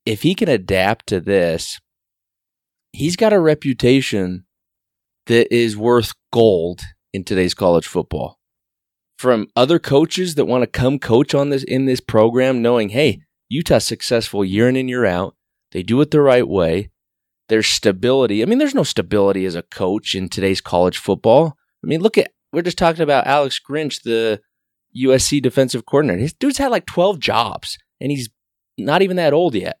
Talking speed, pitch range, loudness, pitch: 175 wpm, 105-145 Hz, -17 LUFS, 125 Hz